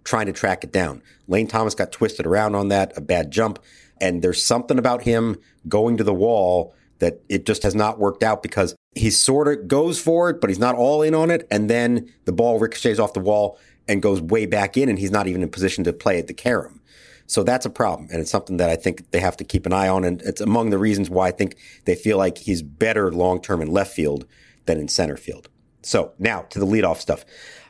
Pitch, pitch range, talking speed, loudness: 100 Hz, 95-115 Hz, 245 wpm, -21 LUFS